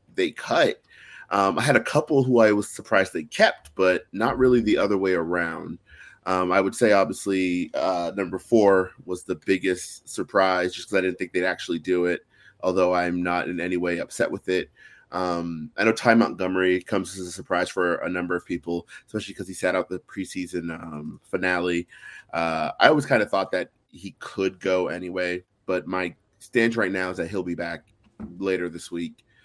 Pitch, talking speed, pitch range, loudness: 90 Hz, 200 wpm, 90-100 Hz, -24 LUFS